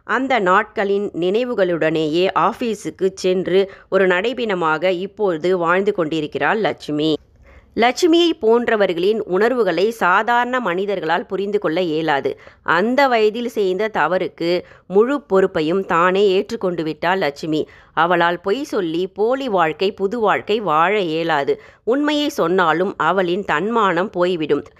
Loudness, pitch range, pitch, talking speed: -18 LUFS, 170-225 Hz, 190 Hz, 105 wpm